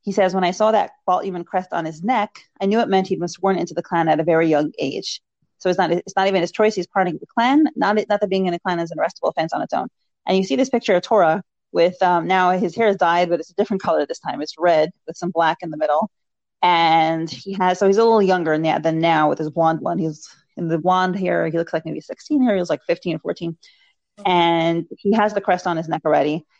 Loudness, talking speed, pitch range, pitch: -19 LUFS, 275 wpm, 165-195 Hz, 180 Hz